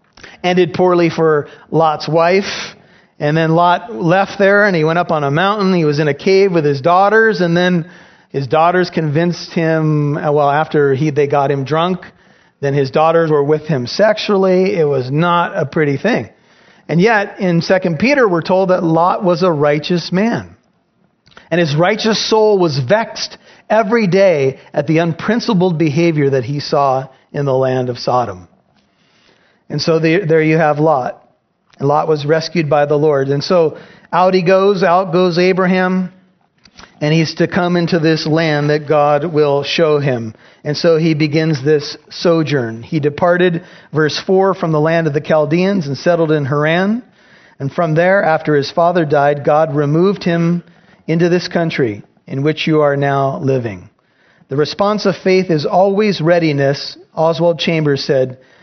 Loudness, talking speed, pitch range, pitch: -14 LUFS, 170 wpm, 150-185 Hz, 165 Hz